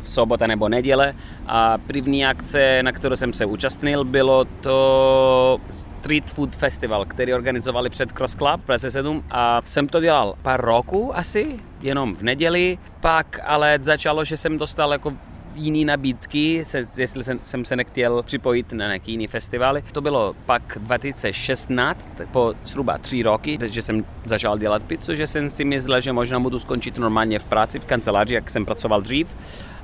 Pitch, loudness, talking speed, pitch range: 130 Hz, -21 LUFS, 170 wpm, 120-145 Hz